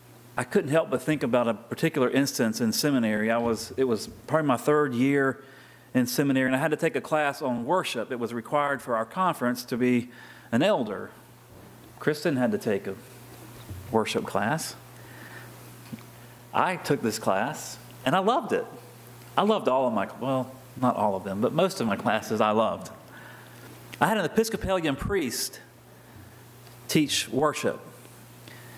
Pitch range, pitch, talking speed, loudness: 120-150 Hz, 130 Hz, 165 wpm, -26 LUFS